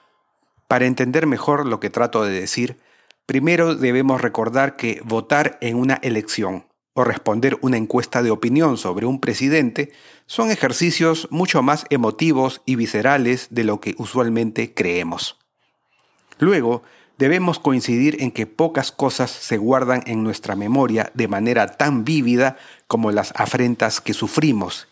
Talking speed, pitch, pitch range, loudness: 140 wpm, 125 Hz, 115-140 Hz, -19 LUFS